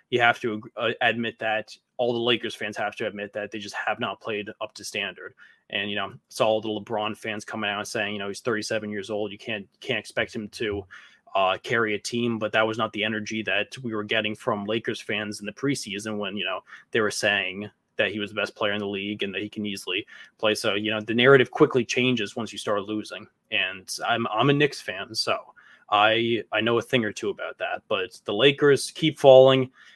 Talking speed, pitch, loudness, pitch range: 235 wpm, 110 Hz, -25 LUFS, 105-120 Hz